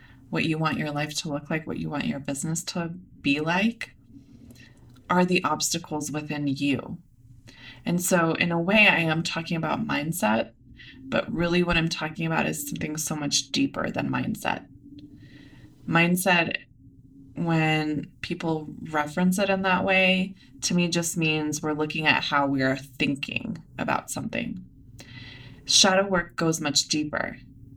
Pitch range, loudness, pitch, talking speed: 140-170 Hz, -25 LUFS, 155 Hz, 150 wpm